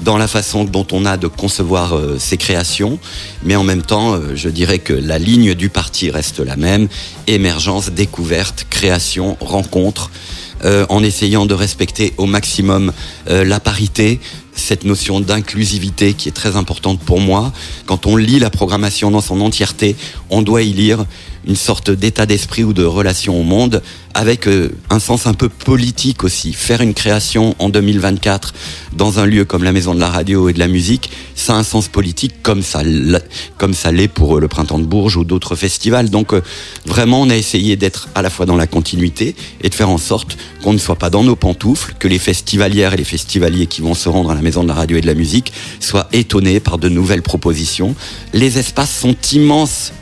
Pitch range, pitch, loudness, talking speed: 90-105 Hz, 100 Hz, -13 LUFS, 200 wpm